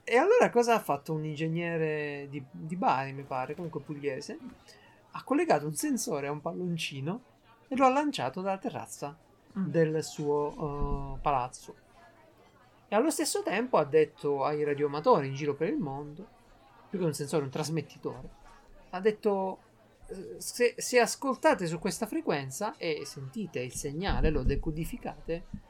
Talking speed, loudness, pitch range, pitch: 150 wpm, -31 LUFS, 145-210 Hz, 160 Hz